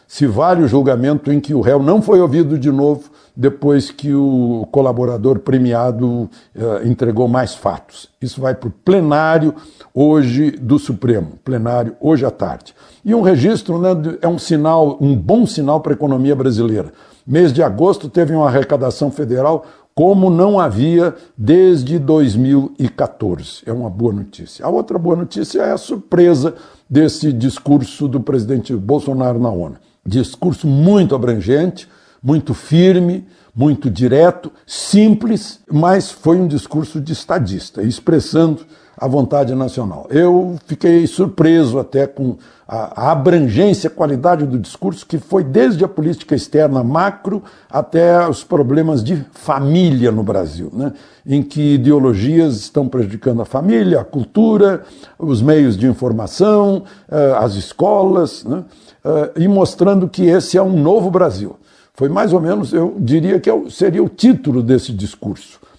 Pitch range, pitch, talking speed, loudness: 130-170 Hz, 150 Hz, 145 wpm, -14 LUFS